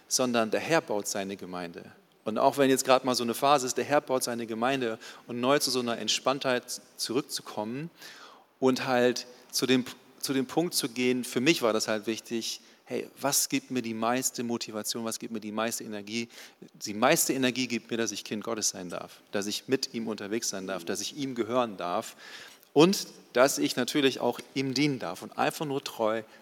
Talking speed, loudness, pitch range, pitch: 205 wpm, -29 LUFS, 115-135 Hz, 125 Hz